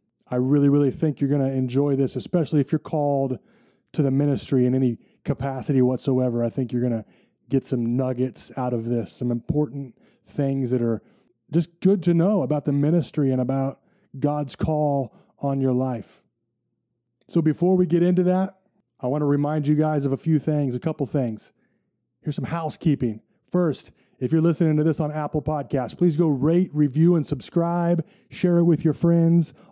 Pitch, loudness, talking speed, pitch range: 145 Hz, -23 LUFS, 185 wpm, 130-160 Hz